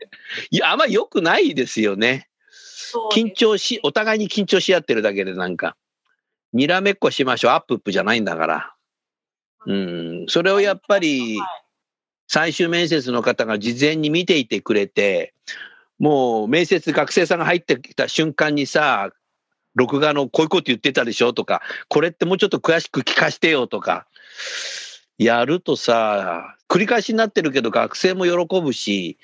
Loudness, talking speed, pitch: -19 LUFS, 310 characters per minute, 170 Hz